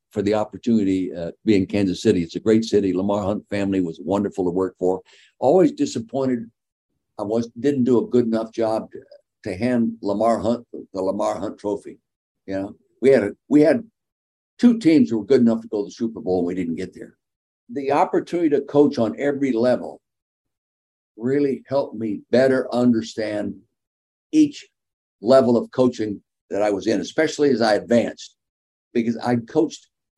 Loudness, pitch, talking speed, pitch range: -21 LUFS, 115 Hz, 185 wpm, 100-135 Hz